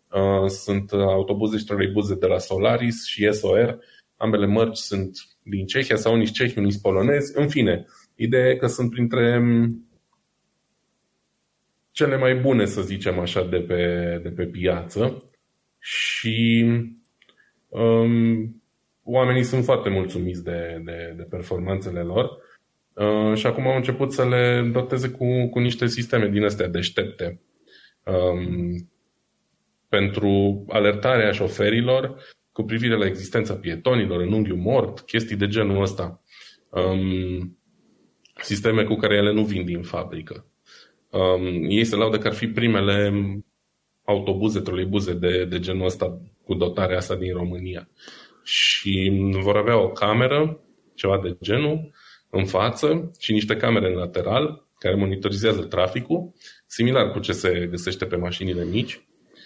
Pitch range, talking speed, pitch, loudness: 95-115 Hz, 135 wpm, 105 Hz, -22 LUFS